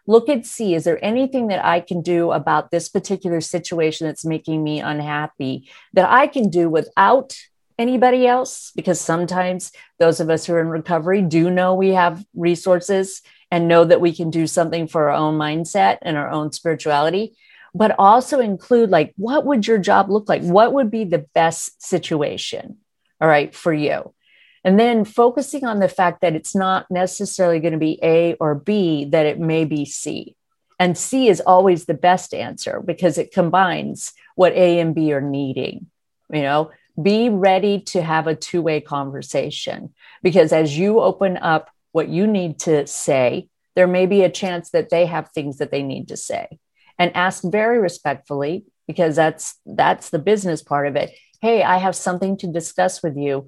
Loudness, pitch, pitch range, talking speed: -18 LUFS, 175 Hz, 160-195 Hz, 185 wpm